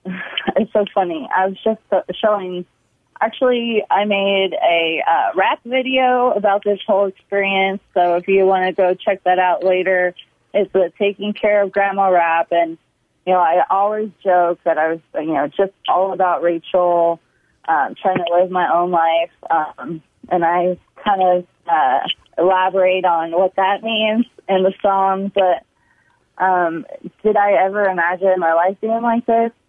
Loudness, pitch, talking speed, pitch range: -17 LUFS, 190 Hz, 165 wpm, 175-205 Hz